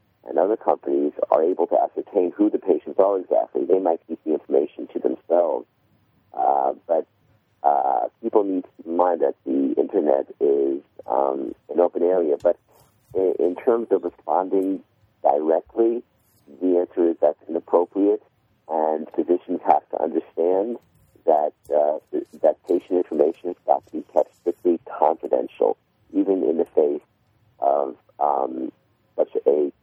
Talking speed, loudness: 145 wpm, -22 LUFS